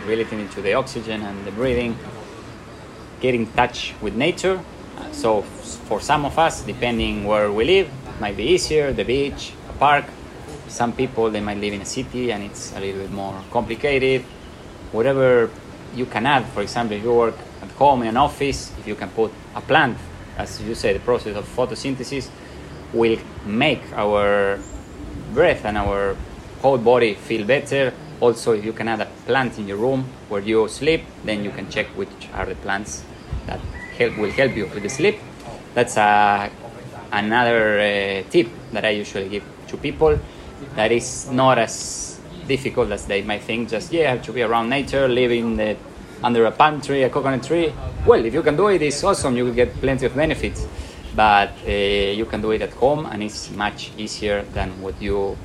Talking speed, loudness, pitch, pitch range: 185 wpm, -21 LUFS, 115 Hz, 100-130 Hz